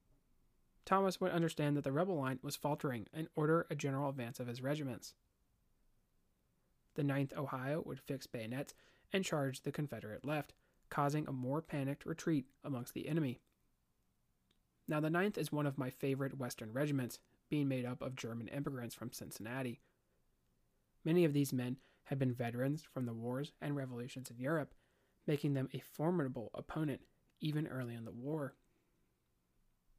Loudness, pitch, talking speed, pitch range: -40 LUFS, 140 Hz, 155 wpm, 125-150 Hz